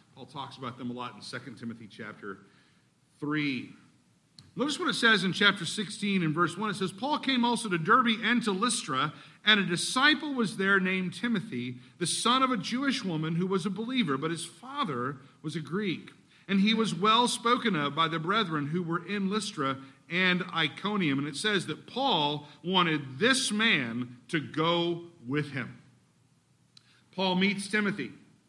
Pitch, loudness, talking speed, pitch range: 180 Hz, -28 LUFS, 175 wpm, 150-215 Hz